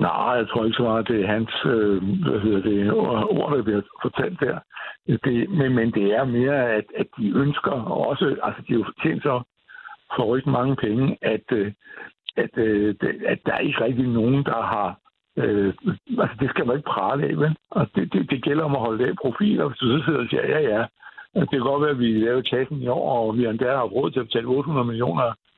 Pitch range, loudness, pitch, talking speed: 110-140 Hz, -23 LUFS, 120 Hz, 230 wpm